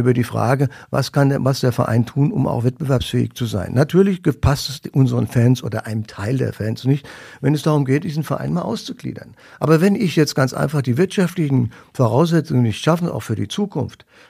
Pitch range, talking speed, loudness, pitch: 120-155 Hz, 205 wpm, -19 LUFS, 135 Hz